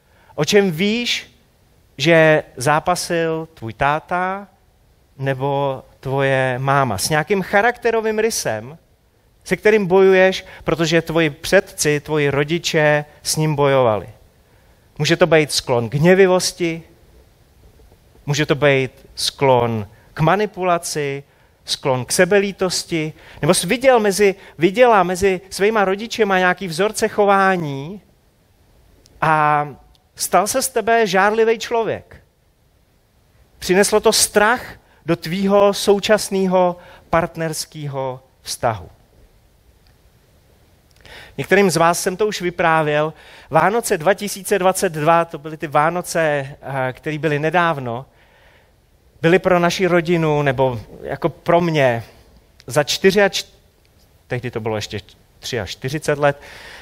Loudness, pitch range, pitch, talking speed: -17 LUFS, 135-190 Hz, 160 Hz, 105 wpm